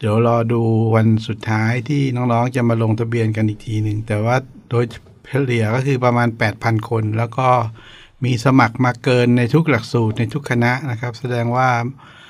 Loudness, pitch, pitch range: -18 LUFS, 120 Hz, 110-125 Hz